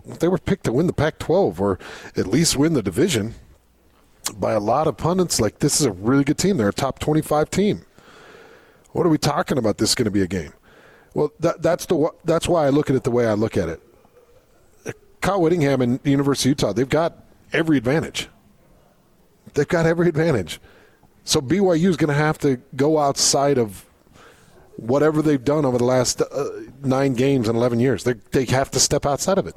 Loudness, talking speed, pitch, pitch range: -20 LUFS, 210 wpm, 140 Hz, 125-160 Hz